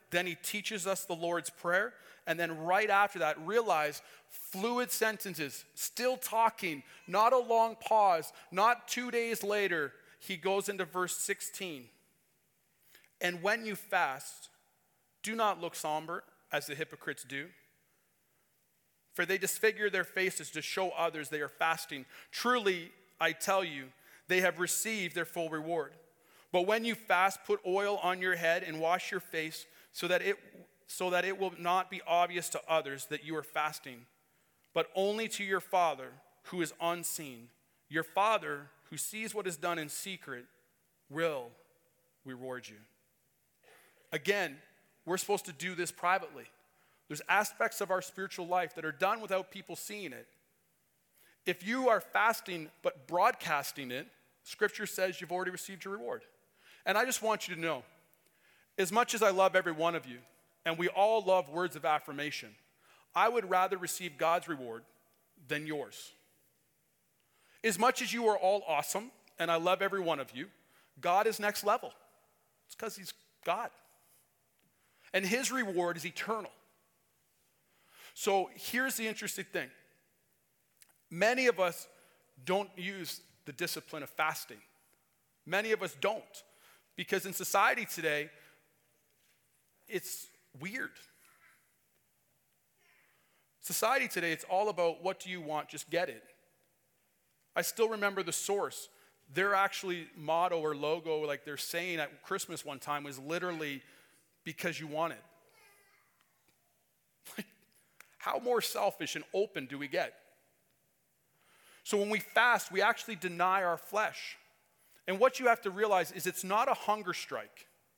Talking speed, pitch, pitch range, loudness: 150 wpm, 180 Hz, 155-200 Hz, -33 LUFS